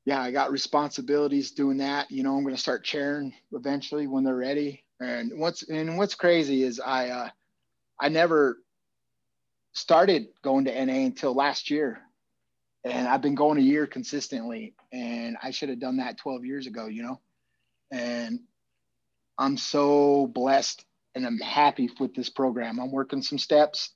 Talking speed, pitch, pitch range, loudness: 165 wpm, 135 Hz, 130-145 Hz, -26 LUFS